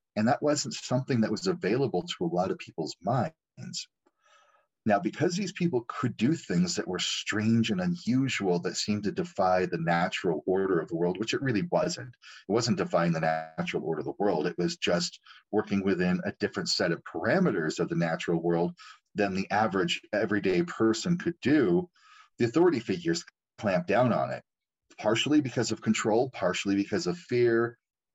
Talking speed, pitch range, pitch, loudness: 180 wpm, 90-135 Hz, 105 Hz, -28 LUFS